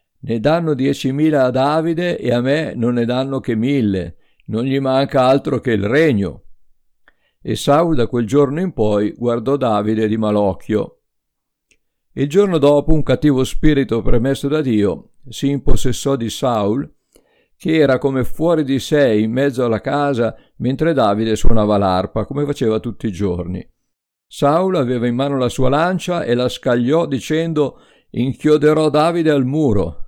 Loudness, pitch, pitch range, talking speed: -17 LUFS, 130 Hz, 115-145 Hz, 155 wpm